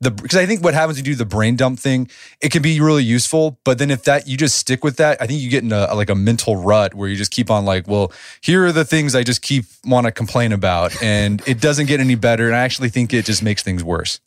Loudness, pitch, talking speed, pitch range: -16 LUFS, 125 Hz, 290 wpm, 105-145 Hz